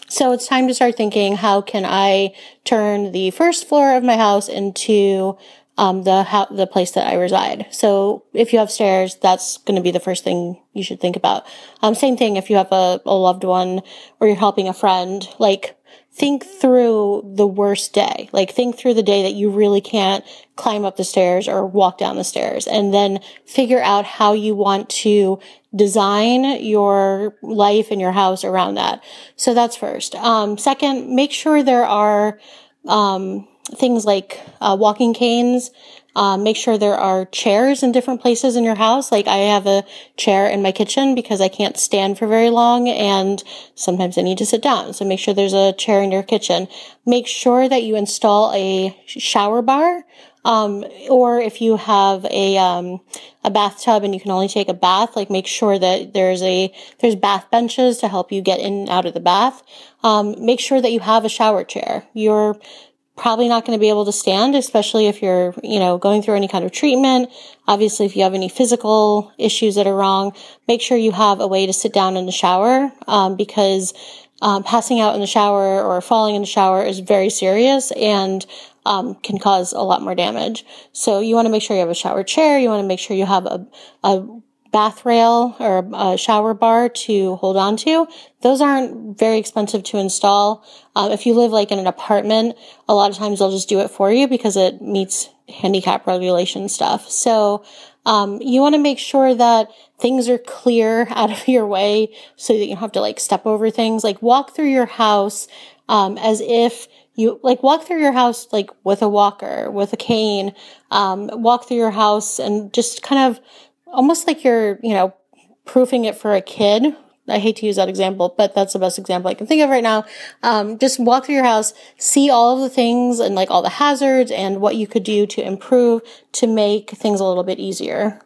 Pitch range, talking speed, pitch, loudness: 195-240 Hz, 210 wpm, 210 Hz, -16 LUFS